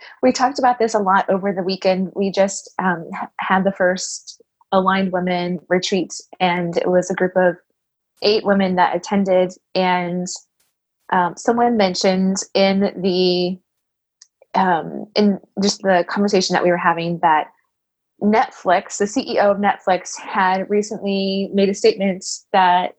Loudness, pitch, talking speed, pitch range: -18 LUFS, 190 Hz, 145 wpm, 180-200 Hz